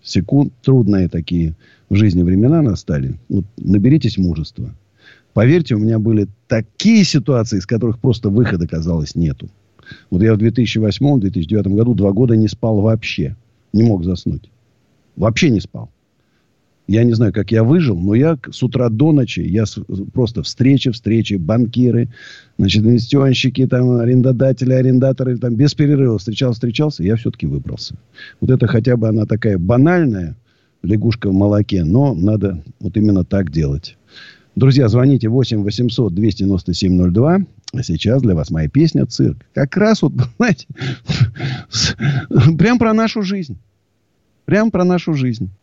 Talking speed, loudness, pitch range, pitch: 145 wpm, -15 LUFS, 100-130 Hz, 115 Hz